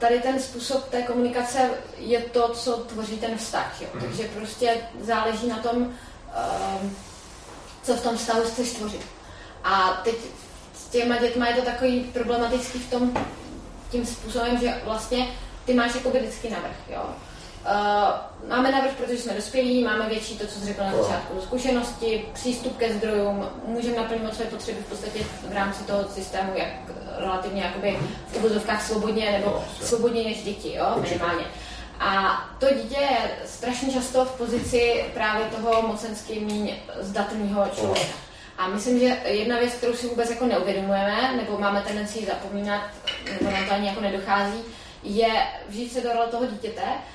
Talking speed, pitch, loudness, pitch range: 160 wpm, 230 Hz, -26 LUFS, 205-245 Hz